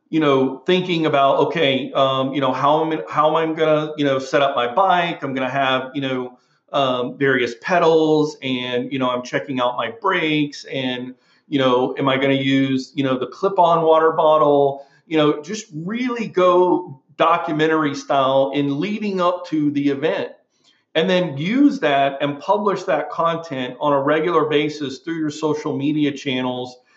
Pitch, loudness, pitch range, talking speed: 145 Hz, -19 LUFS, 135-160 Hz, 185 wpm